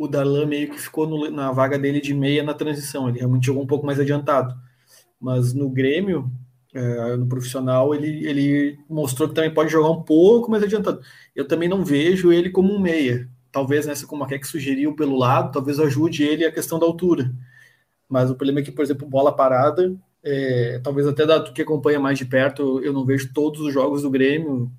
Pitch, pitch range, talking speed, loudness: 145 Hz, 130-155 Hz, 210 wpm, -20 LUFS